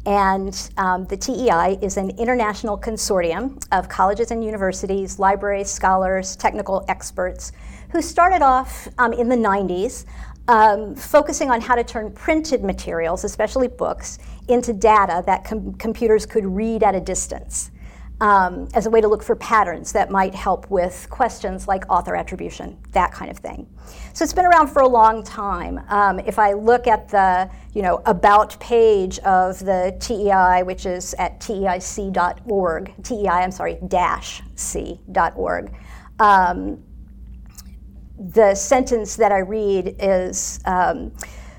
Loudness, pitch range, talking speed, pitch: -19 LUFS, 185-225 Hz, 150 wpm, 200 Hz